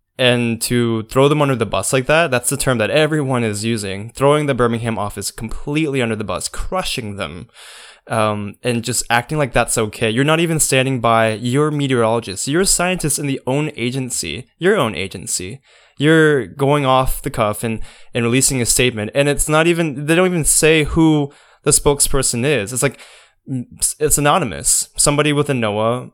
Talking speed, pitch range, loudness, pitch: 180 wpm, 115-145 Hz, -16 LUFS, 130 Hz